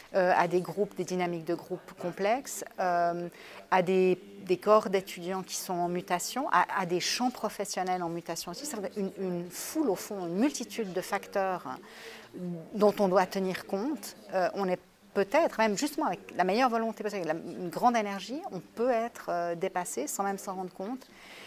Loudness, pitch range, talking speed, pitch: -31 LUFS, 180-220 Hz, 185 wpm, 195 Hz